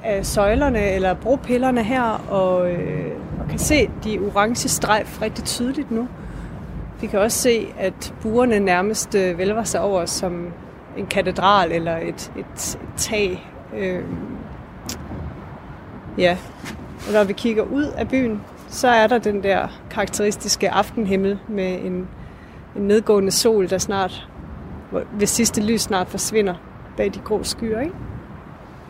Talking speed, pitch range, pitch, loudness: 140 wpm, 185-225 Hz, 205 Hz, -20 LUFS